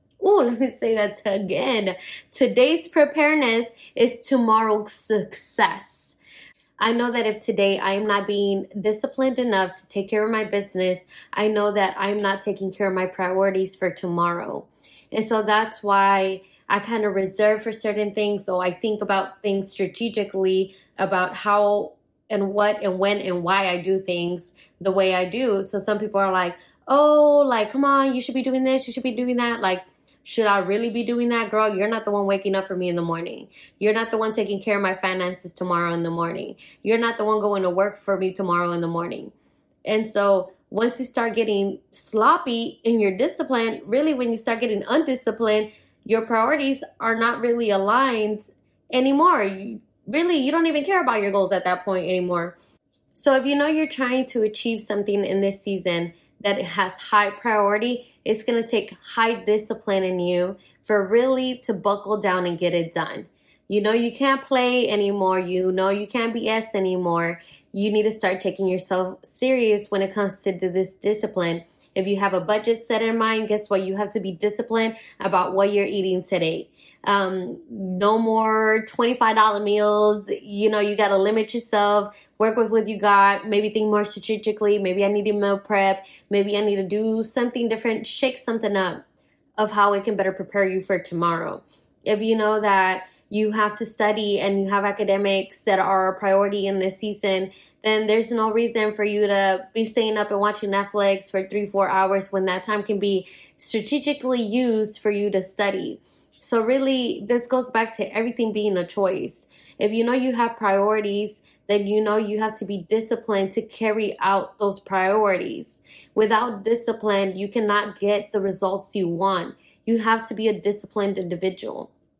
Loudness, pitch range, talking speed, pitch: -22 LUFS, 195-225 Hz, 190 wpm, 210 Hz